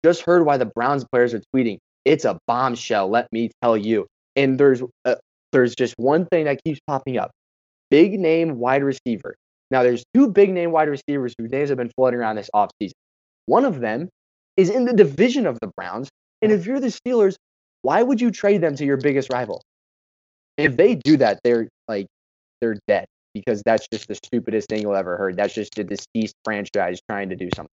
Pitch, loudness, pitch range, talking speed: 130 Hz, -20 LUFS, 110-165 Hz, 205 wpm